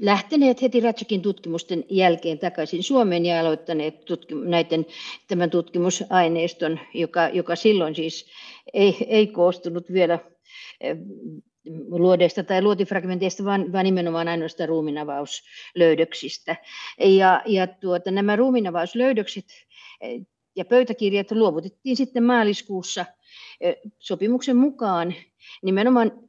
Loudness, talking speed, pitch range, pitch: -22 LUFS, 95 wpm, 170-215 Hz, 185 Hz